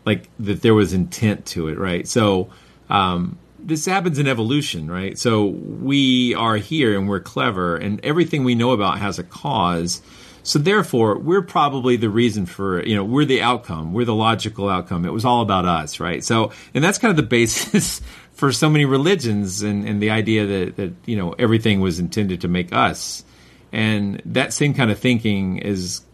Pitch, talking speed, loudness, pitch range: 110 Hz, 195 wpm, -19 LUFS, 95-125 Hz